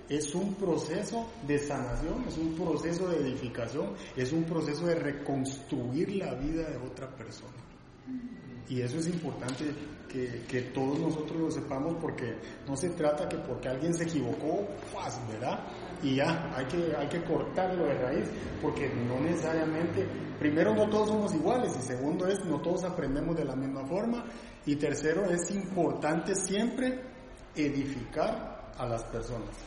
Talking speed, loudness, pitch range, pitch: 155 wpm, -32 LUFS, 130-170 Hz, 150 Hz